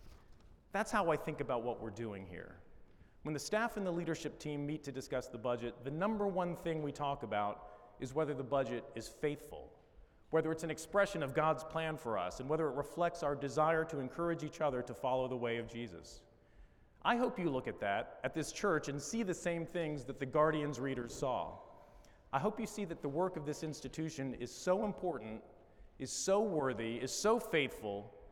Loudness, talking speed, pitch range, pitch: -38 LUFS, 205 wpm, 125-165 Hz, 145 Hz